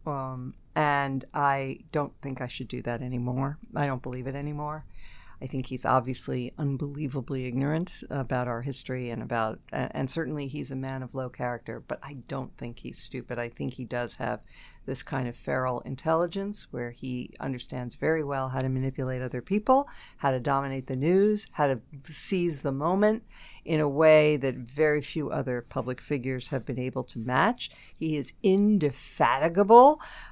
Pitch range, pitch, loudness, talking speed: 125-150 Hz, 135 Hz, -28 LUFS, 170 wpm